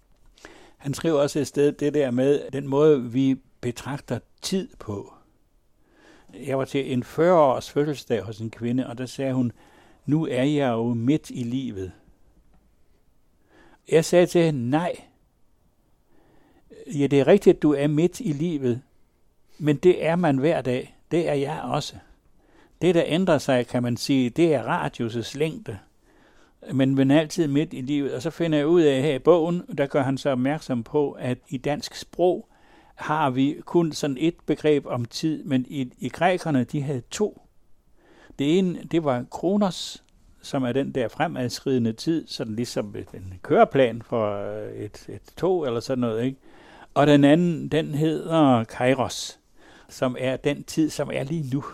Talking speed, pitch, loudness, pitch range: 170 wpm, 140 Hz, -23 LUFS, 125-155 Hz